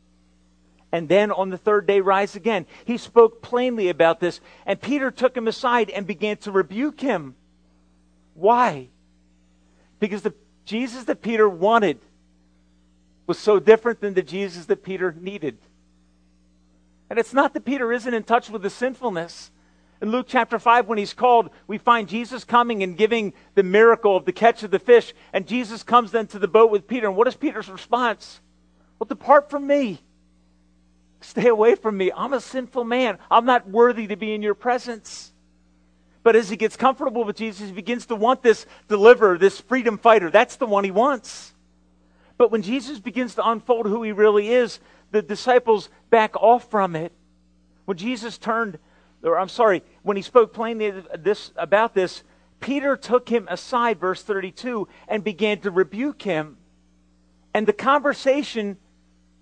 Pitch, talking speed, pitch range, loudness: 210 Hz, 170 wpm, 165-235 Hz, -21 LUFS